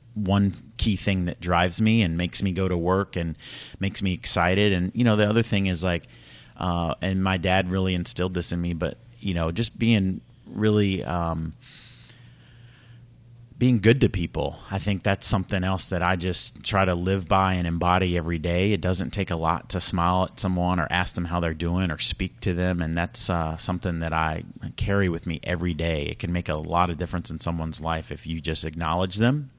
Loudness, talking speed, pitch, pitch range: -23 LUFS, 215 wpm, 90 Hz, 85-100 Hz